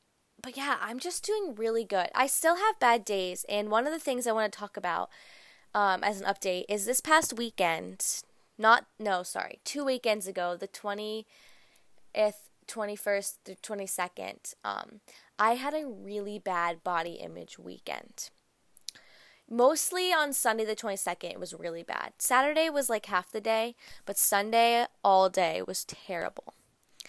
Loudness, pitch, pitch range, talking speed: -29 LUFS, 215 Hz, 190-250 Hz, 155 wpm